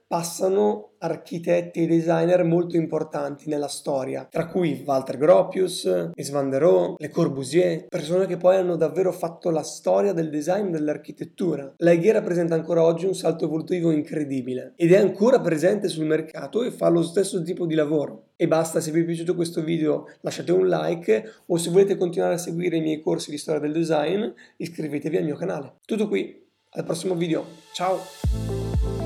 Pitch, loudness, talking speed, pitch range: 170 Hz, -23 LUFS, 170 wpm, 155-180 Hz